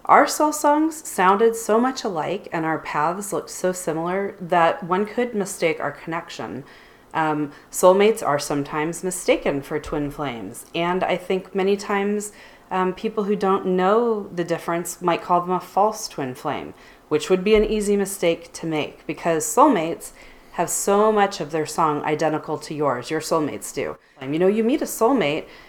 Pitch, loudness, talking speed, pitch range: 180 Hz, -22 LUFS, 175 wpm, 160-205 Hz